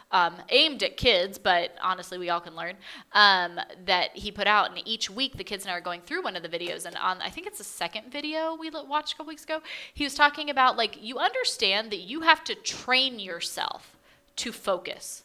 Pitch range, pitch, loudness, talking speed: 180-300 Hz, 215 Hz, -26 LUFS, 230 wpm